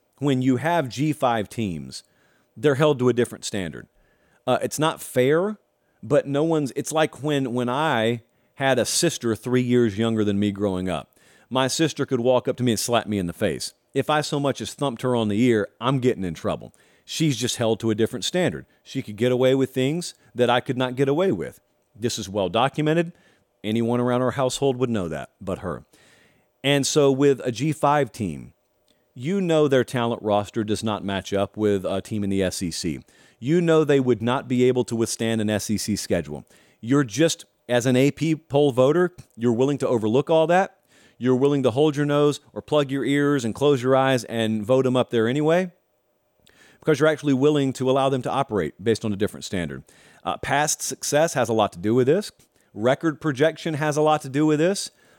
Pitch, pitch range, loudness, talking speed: 130 Hz, 115-145 Hz, -23 LUFS, 210 wpm